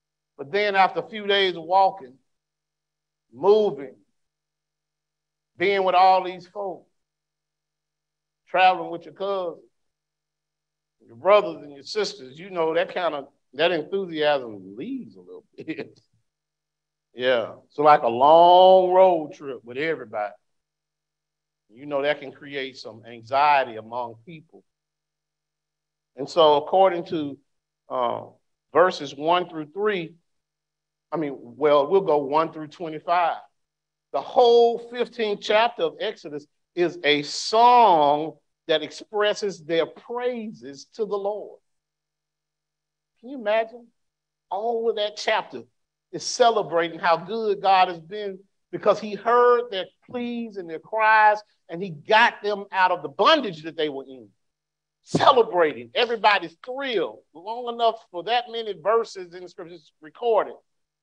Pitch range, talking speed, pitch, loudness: 155-205 Hz, 130 wpm, 170 Hz, -22 LUFS